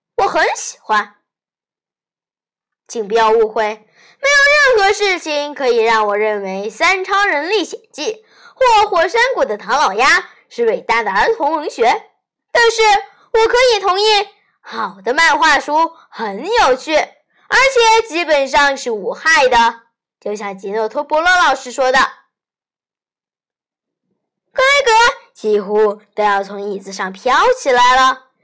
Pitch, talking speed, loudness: 295 Hz, 195 characters per minute, -14 LUFS